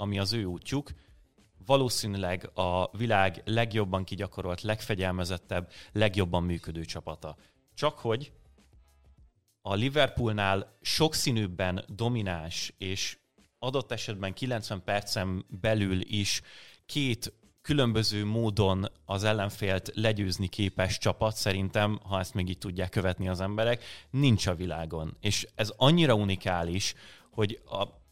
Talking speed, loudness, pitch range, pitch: 110 wpm, -30 LUFS, 95-110 Hz, 100 Hz